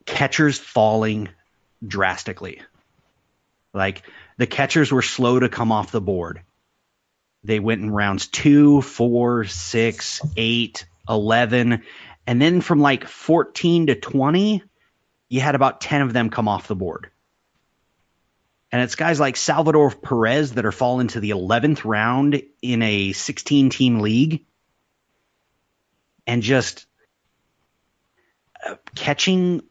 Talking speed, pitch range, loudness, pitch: 125 wpm, 110-145 Hz, -19 LUFS, 120 Hz